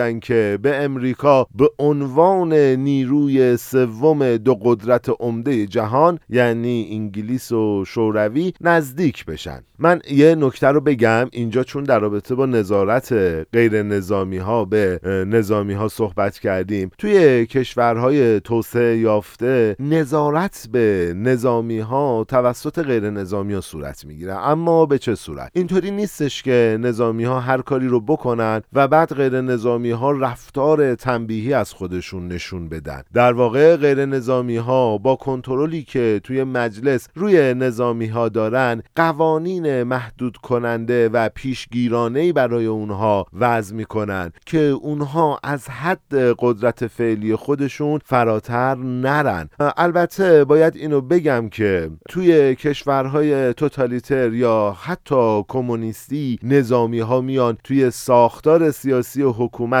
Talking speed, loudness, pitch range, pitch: 125 wpm, -18 LUFS, 110-140 Hz, 125 Hz